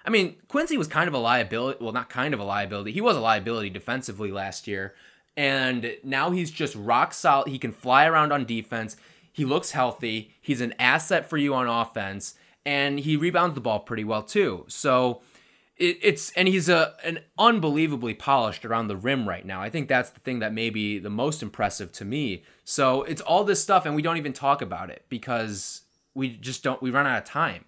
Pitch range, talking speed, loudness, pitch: 115-155 Hz, 215 wpm, -25 LUFS, 130 Hz